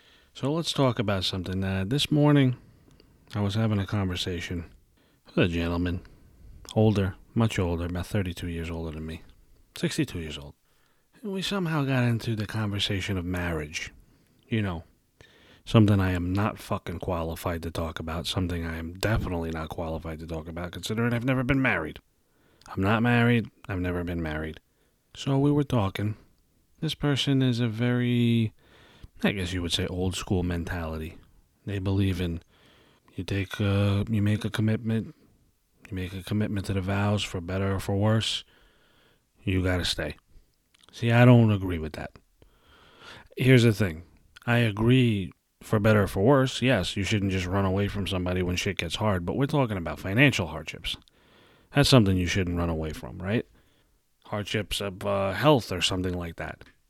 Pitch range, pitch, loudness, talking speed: 85-115 Hz, 100 Hz, -27 LUFS, 170 wpm